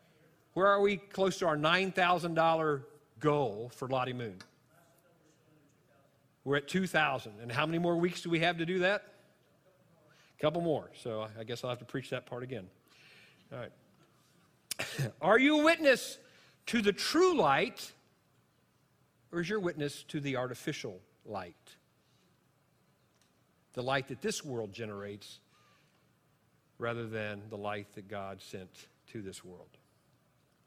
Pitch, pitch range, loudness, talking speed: 150 Hz, 125-175 Hz, -32 LUFS, 145 wpm